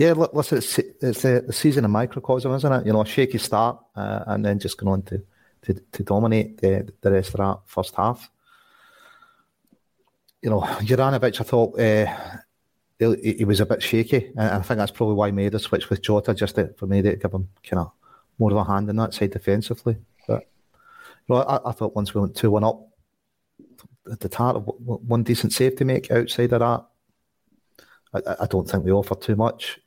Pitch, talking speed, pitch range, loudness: 110 Hz, 205 wpm, 100-125 Hz, -23 LUFS